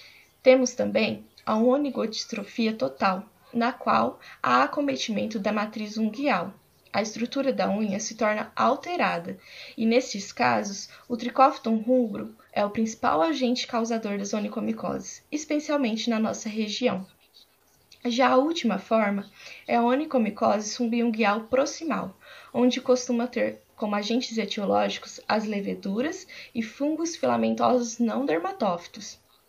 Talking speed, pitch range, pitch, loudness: 120 wpm, 215-255 Hz, 230 Hz, -26 LUFS